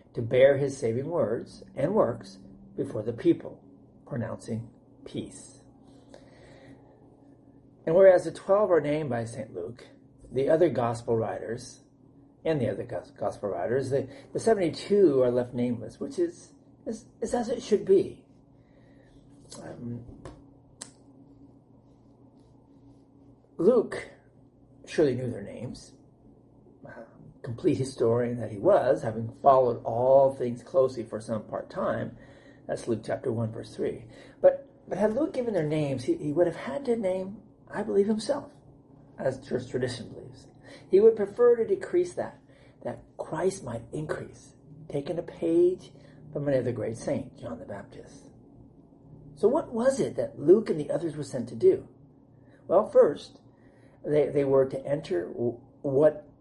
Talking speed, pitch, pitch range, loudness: 140 wpm, 140 Hz, 130-175 Hz, -27 LUFS